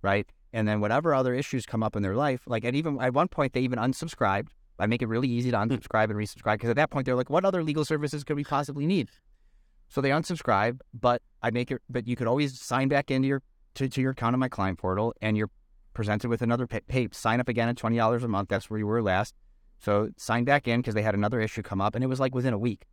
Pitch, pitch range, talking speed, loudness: 120 Hz, 110-130 Hz, 270 wpm, -28 LUFS